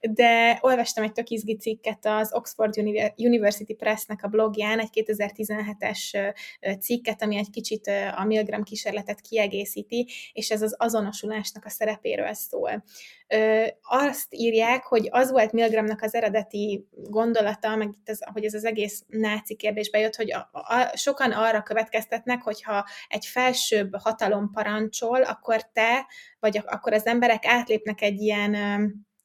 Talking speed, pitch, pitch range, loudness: 140 wpm, 220 Hz, 210-230 Hz, -25 LUFS